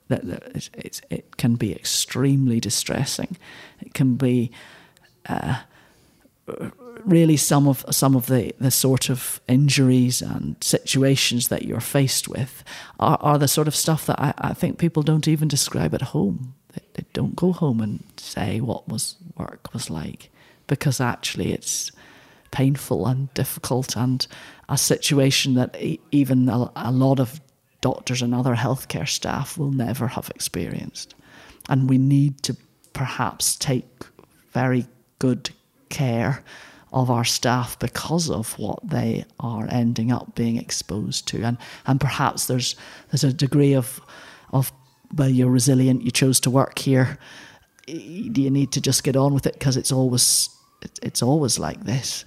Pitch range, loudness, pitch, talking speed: 125-140 Hz, -22 LUFS, 130 Hz, 155 wpm